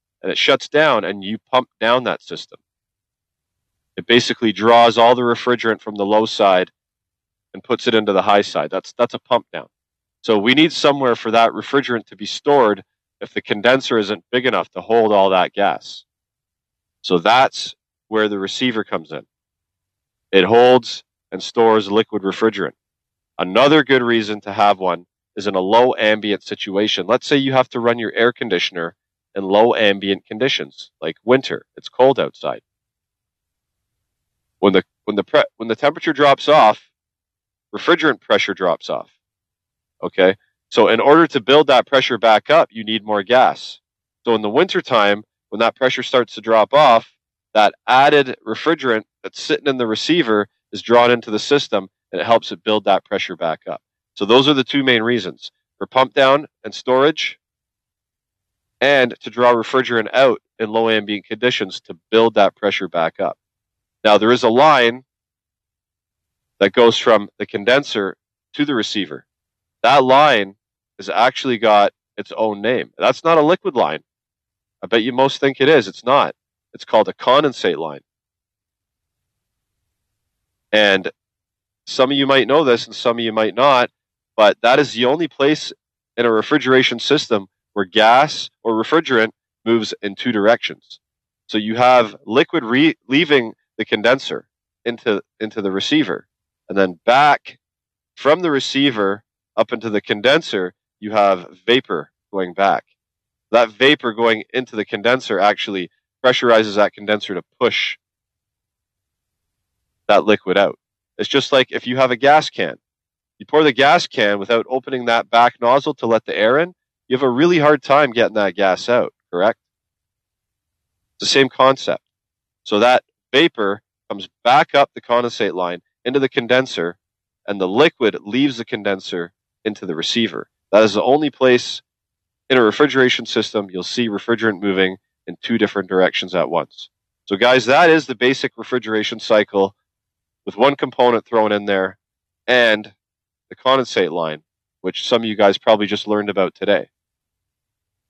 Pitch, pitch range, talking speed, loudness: 110 Hz, 100-125 Hz, 165 wpm, -16 LUFS